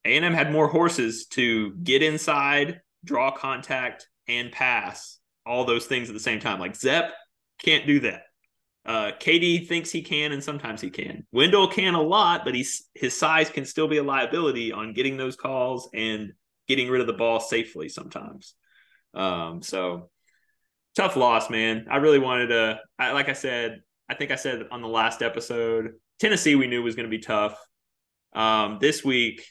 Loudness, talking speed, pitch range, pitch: -24 LUFS, 180 wpm, 110-150 Hz, 125 Hz